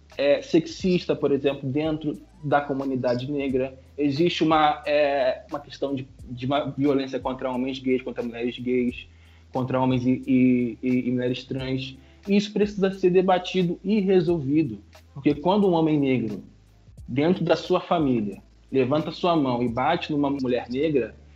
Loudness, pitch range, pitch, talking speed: -24 LUFS, 125-165 Hz, 140 Hz, 155 wpm